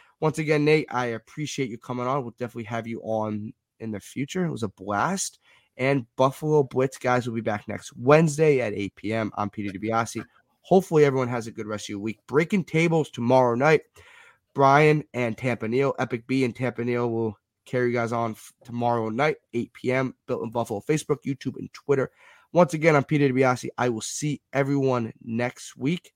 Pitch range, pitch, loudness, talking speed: 115-145 Hz, 125 Hz, -25 LUFS, 190 wpm